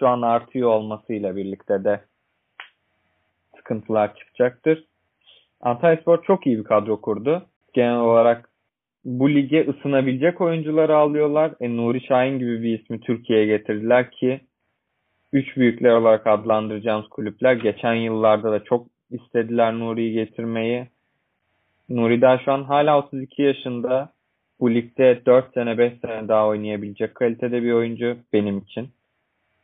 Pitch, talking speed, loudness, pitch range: 120 Hz, 125 wpm, -21 LUFS, 110-130 Hz